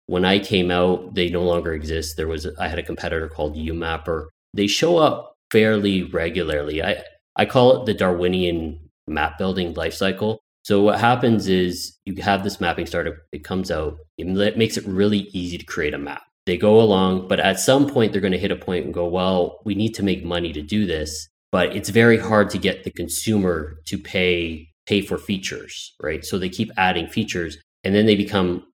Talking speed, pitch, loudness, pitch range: 205 wpm, 95 Hz, -21 LUFS, 85-105 Hz